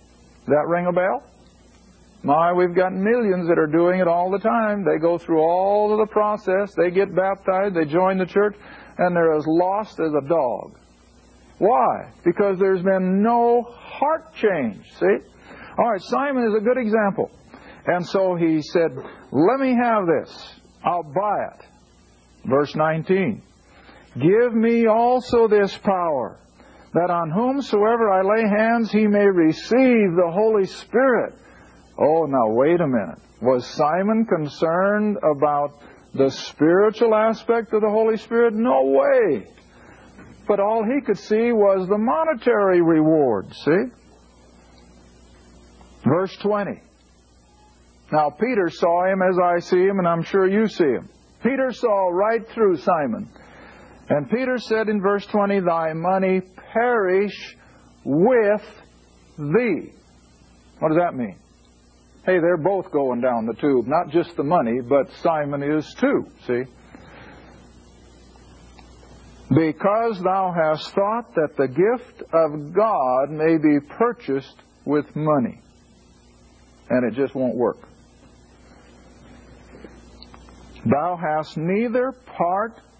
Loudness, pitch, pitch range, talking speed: -20 LUFS, 175 Hz, 125-210 Hz, 135 wpm